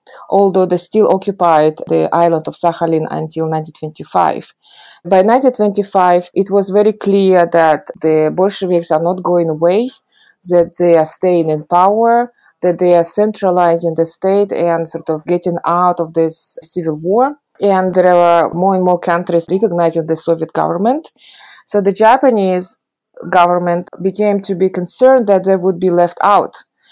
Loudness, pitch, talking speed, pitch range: -13 LUFS, 180 Hz, 155 wpm, 170-200 Hz